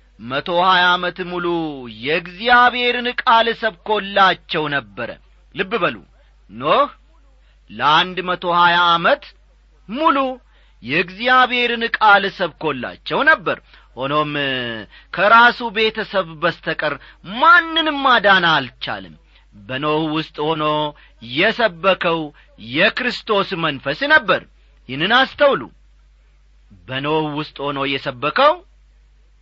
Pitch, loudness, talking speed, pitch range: 175 Hz, -17 LUFS, 80 wpm, 145-230 Hz